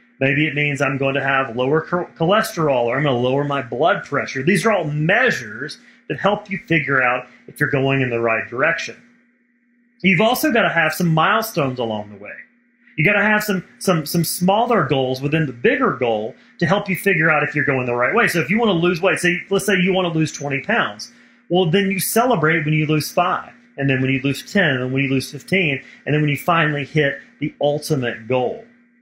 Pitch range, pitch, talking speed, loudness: 135-195 Hz, 155 Hz, 230 wpm, -18 LUFS